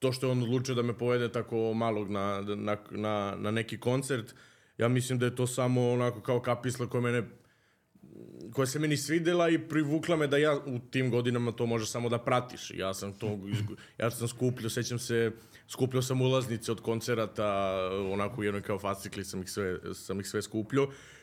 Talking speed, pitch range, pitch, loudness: 195 wpm, 105-130 Hz, 120 Hz, -31 LUFS